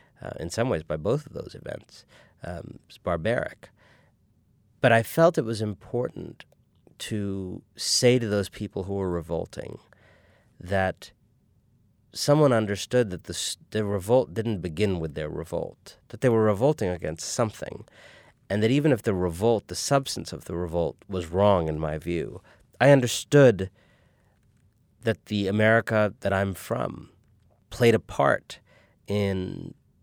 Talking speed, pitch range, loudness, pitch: 140 wpm, 95-115 Hz, -25 LUFS, 105 Hz